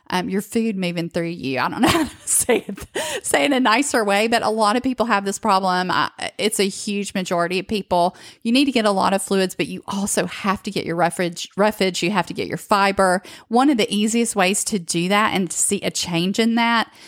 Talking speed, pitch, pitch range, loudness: 255 wpm, 200 Hz, 180-220 Hz, -20 LUFS